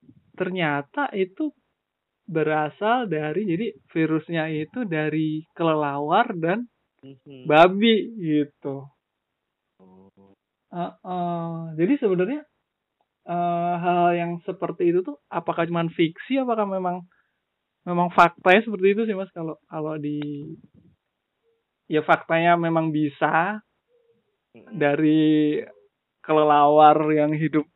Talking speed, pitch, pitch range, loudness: 95 wpm, 170 Hz, 155-190 Hz, -22 LUFS